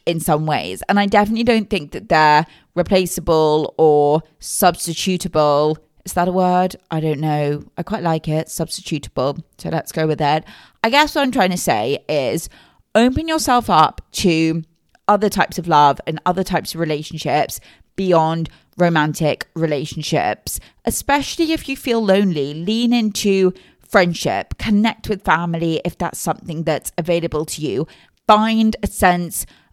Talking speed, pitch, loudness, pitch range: 150 wpm, 170 Hz, -18 LUFS, 155-205 Hz